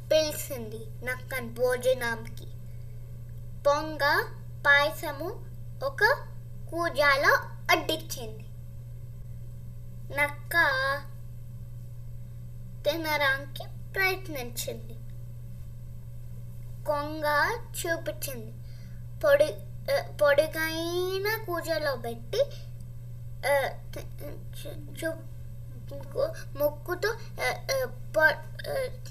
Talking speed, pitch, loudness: 40 wpm, 120 Hz, -28 LUFS